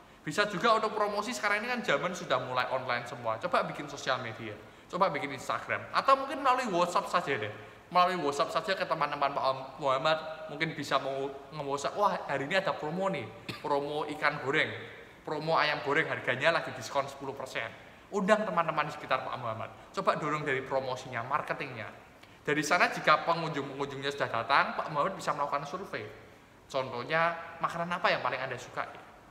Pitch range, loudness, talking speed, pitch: 130-175 Hz, -31 LUFS, 165 wpm, 145 Hz